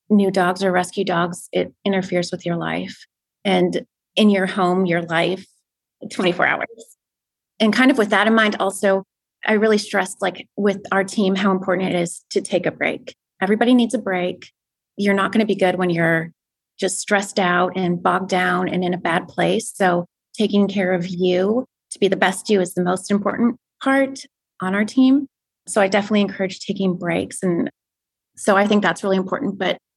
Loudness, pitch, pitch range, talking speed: -19 LUFS, 195 Hz, 180-210 Hz, 190 wpm